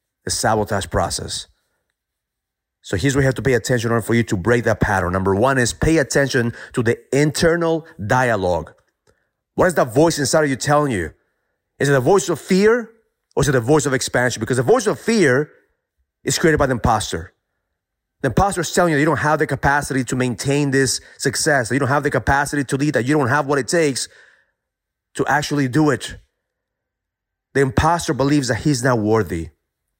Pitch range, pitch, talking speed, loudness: 115-150 Hz, 135 Hz, 200 wpm, -18 LUFS